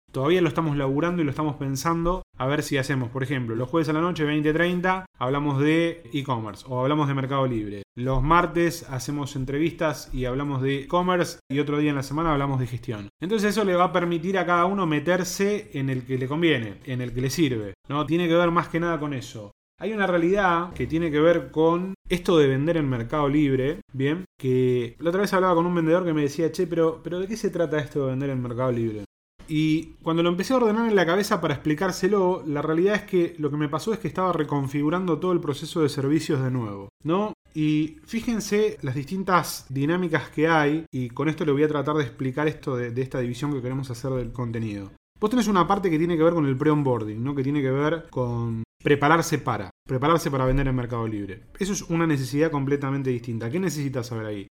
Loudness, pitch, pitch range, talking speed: -24 LUFS, 150 Hz, 130-170 Hz, 225 wpm